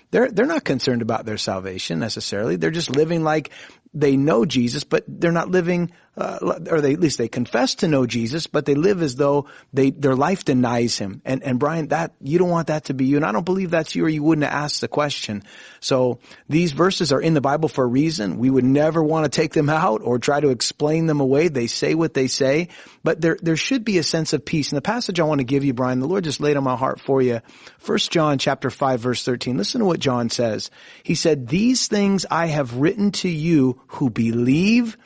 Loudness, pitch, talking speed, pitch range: -20 LUFS, 150 Hz, 240 wpm, 130-165 Hz